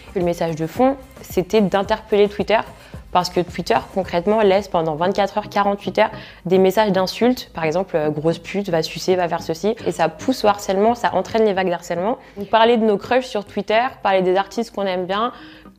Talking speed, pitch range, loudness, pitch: 200 wpm, 180-215 Hz, -19 LUFS, 195 Hz